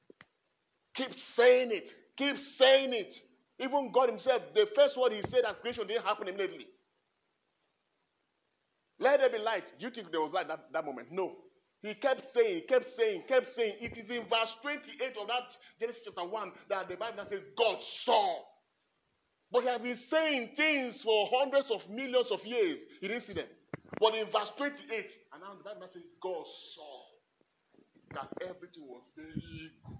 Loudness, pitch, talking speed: -32 LUFS, 255 Hz, 180 wpm